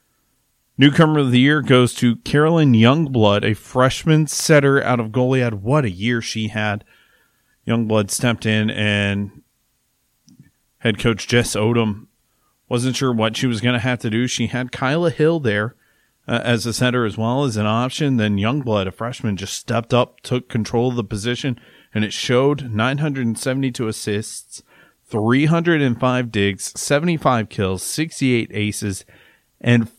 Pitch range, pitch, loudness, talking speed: 110-130 Hz, 120 Hz, -19 LUFS, 150 wpm